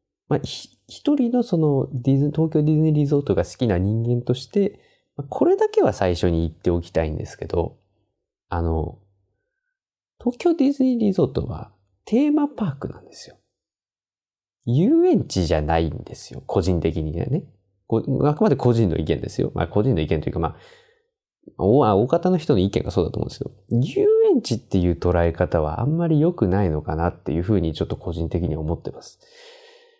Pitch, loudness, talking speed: 120 Hz, -21 LUFS, 360 characters per minute